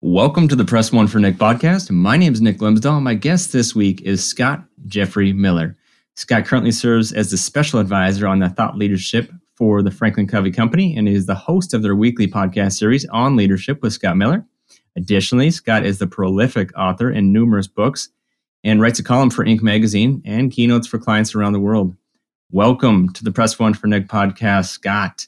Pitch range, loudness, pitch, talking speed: 100-120 Hz, -16 LUFS, 110 Hz, 195 wpm